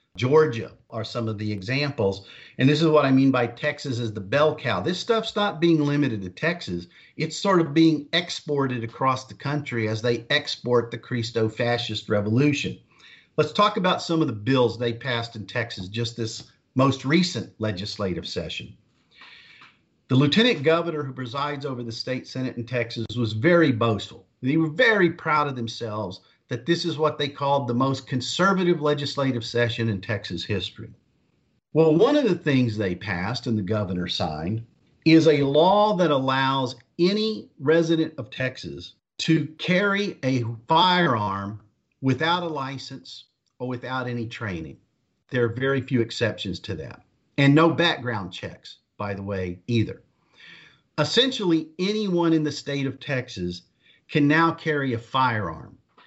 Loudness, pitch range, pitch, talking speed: -23 LUFS, 115-155 Hz, 130 Hz, 160 wpm